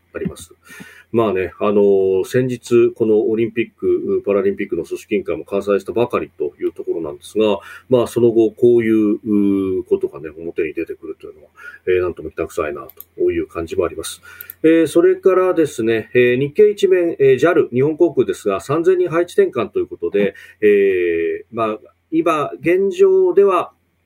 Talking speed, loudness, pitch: 360 characters per minute, -17 LUFS, 360 Hz